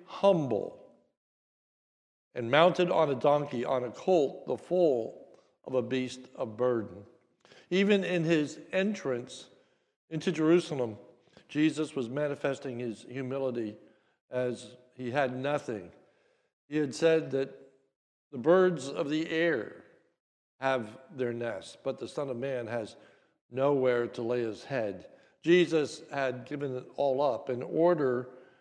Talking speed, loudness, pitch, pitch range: 130 wpm, -30 LUFS, 135 Hz, 125-160 Hz